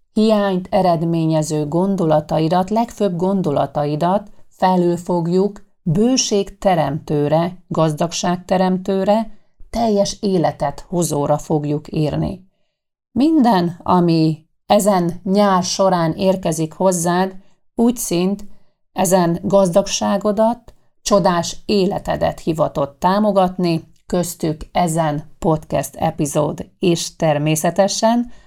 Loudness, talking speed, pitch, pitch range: -18 LUFS, 75 wpm, 180 Hz, 160-200 Hz